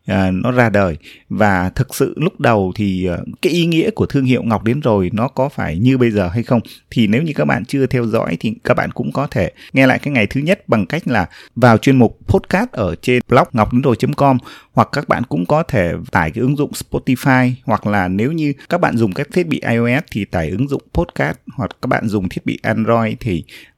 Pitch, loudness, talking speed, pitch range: 125 Hz, -16 LUFS, 235 wpm, 105-135 Hz